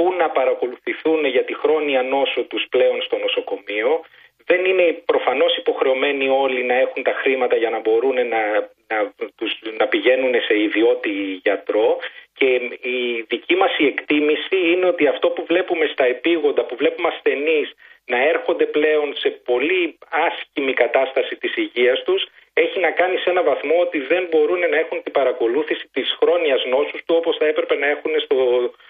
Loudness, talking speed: -19 LUFS, 160 wpm